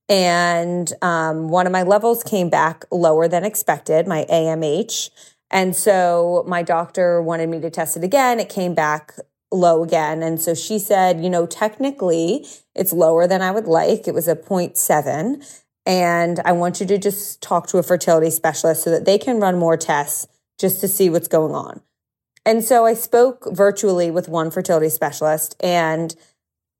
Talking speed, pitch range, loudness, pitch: 175 wpm, 165-195 Hz, -18 LUFS, 175 Hz